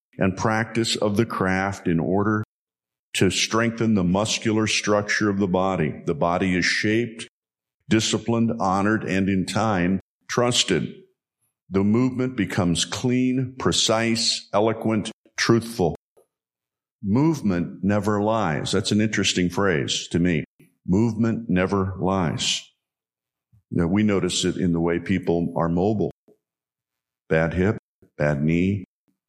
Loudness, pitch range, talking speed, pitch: -22 LUFS, 90-110 Hz, 120 wpm, 100 Hz